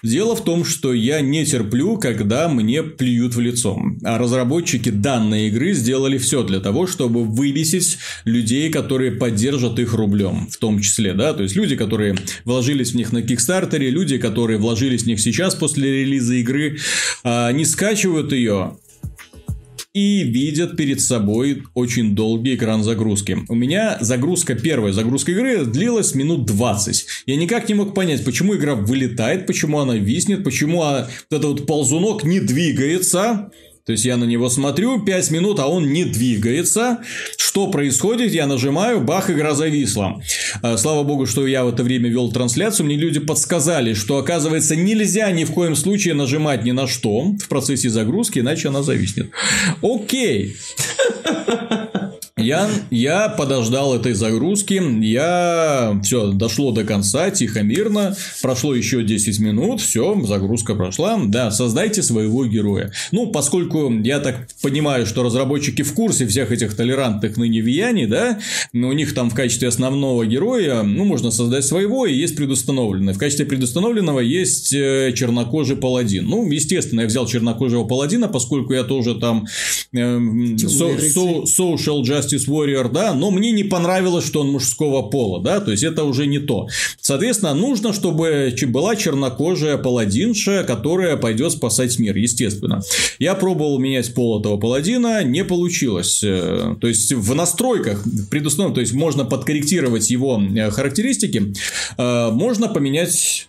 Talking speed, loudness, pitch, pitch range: 150 wpm, -18 LUFS, 135 Hz, 120-170 Hz